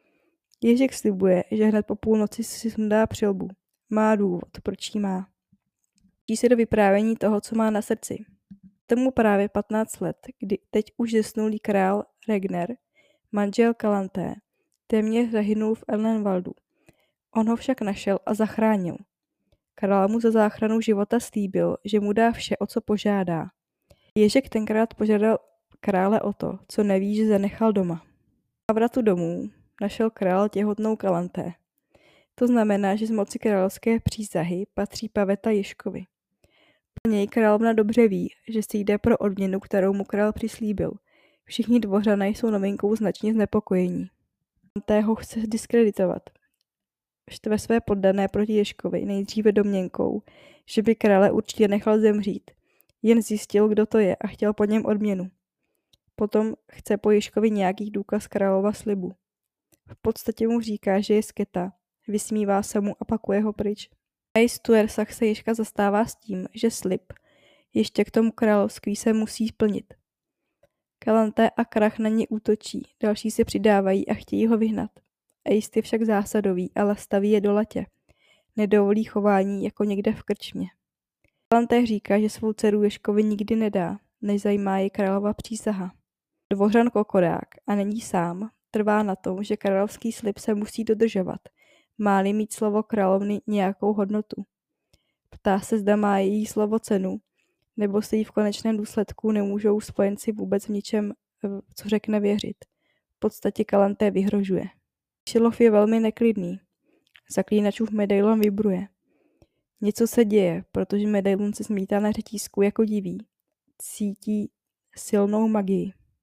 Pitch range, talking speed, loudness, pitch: 200-220 Hz, 145 wpm, -24 LUFS, 210 Hz